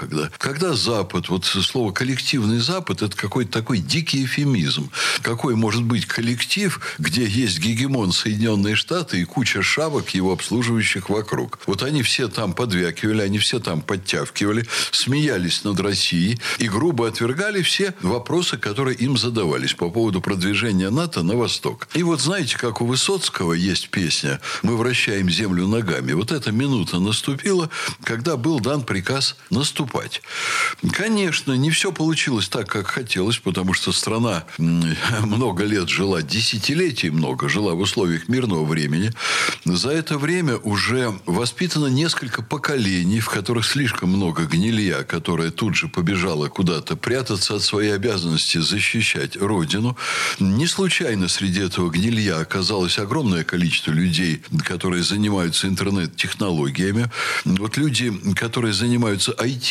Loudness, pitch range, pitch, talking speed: -20 LUFS, 95-135 Hz, 115 Hz, 135 wpm